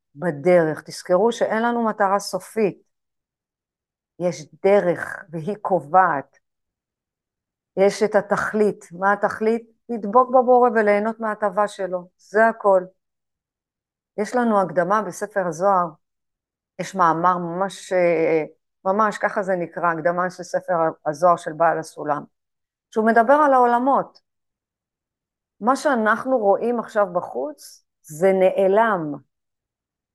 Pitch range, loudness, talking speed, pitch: 175-220 Hz, -20 LUFS, 105 wpm, 195 Hz